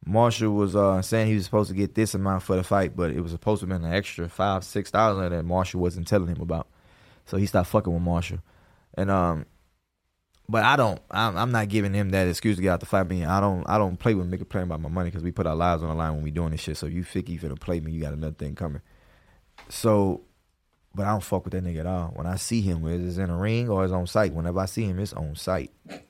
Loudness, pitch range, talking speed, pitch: -26 LUFS, 85-100 Hz, 285 wpm, 95 Hz